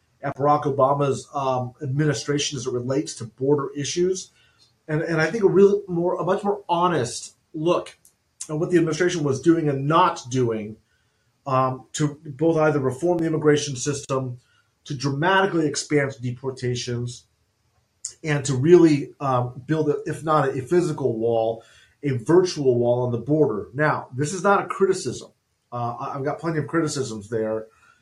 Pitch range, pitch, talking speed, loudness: 125-160 Hz, 140 Hz, 160 wpm, -22 LUFS